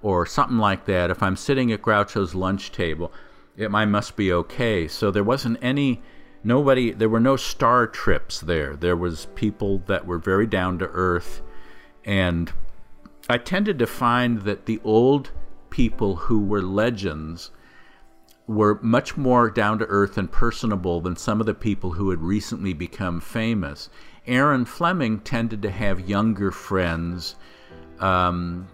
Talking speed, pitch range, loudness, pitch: 155 wpm, 90-115 Hz, -23 LUFS, 100 Hz